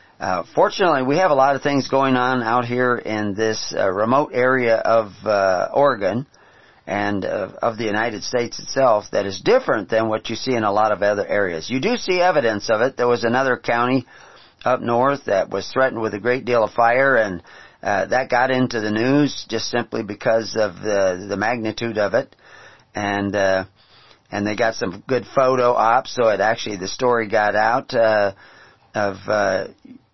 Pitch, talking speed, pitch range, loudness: 115 Hz, 190 wpm, 105-125 Hz, -19 LUFS